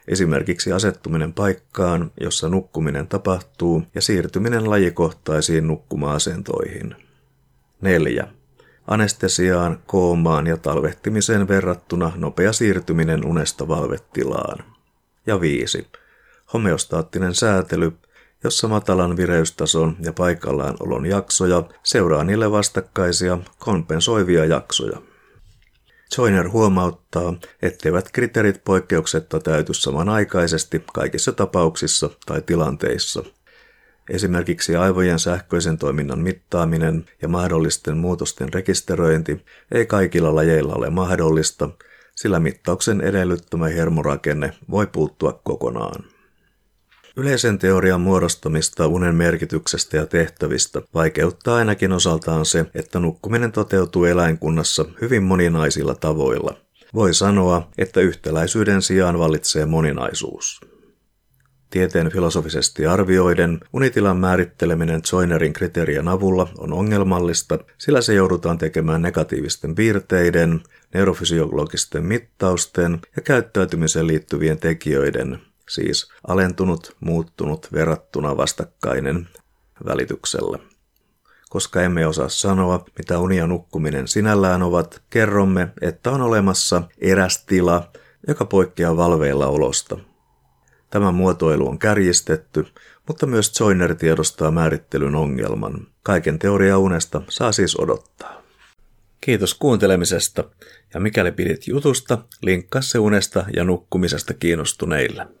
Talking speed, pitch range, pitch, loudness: 95 wpm, 80-95 Hz, 90 Hz, -19 LUFS